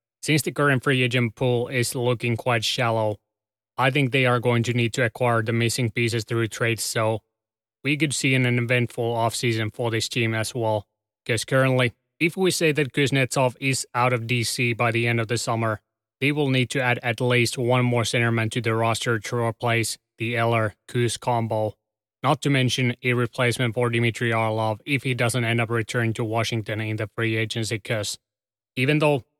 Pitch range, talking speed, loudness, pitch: 115-125 Hz, 195 wpm, -23 LUFS, 120 Hz